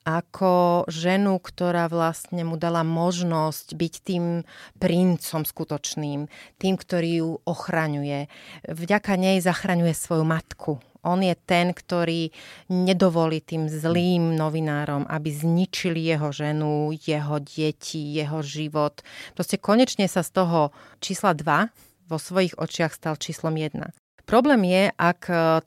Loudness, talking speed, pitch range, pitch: -24 LUFS, 120 wpm, 155-180 Hz, 165 Hz